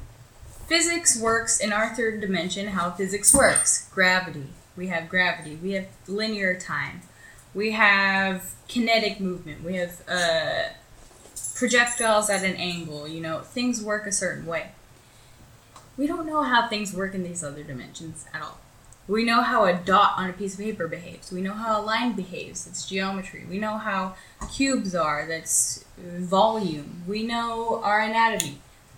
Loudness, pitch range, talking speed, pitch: -24 LUFS, 170-220 Hz, 160 wpm, 190 Hz